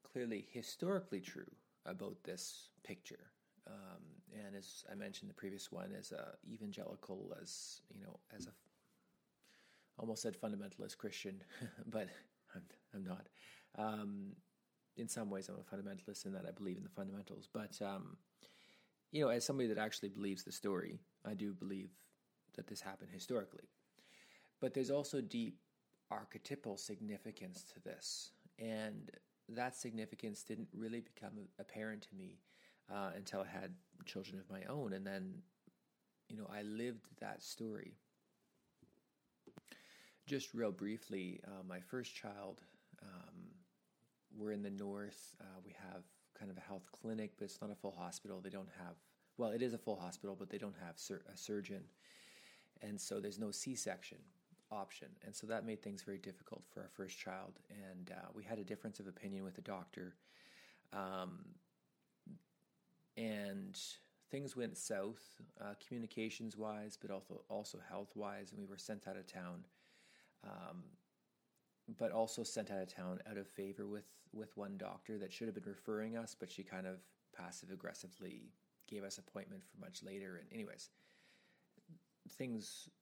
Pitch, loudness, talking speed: 110 Hz, -48 LUFS, 160 wpm